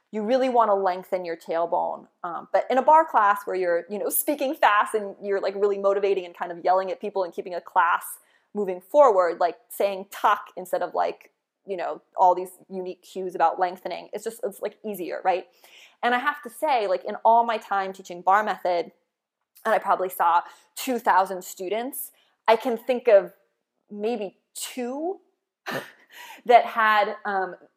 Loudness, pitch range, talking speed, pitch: -24 LUFS, 185-235 Hz, 185 wpm, 200 Hz